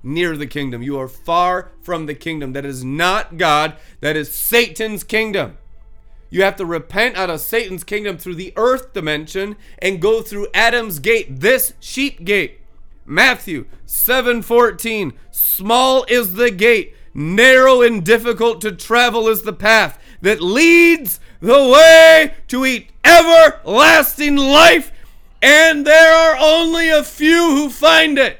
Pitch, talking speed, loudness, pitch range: 225 Hz, 145 wpm, -12 LUFS, 175-275 Hz